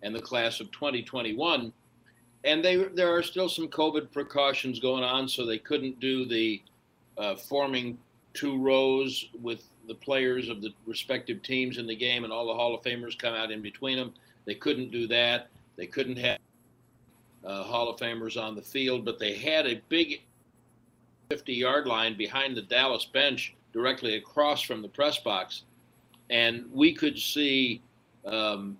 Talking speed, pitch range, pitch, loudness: 170 wpm, 115-135 Hz, 125 Hz, -28 LUFS